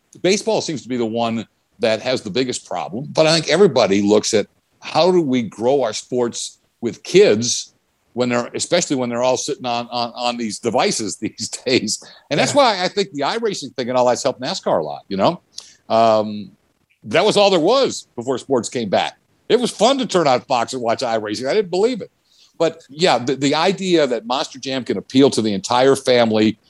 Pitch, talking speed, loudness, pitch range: 125 Hz, 210 wpm, -18 LUFS, 115-160 Hz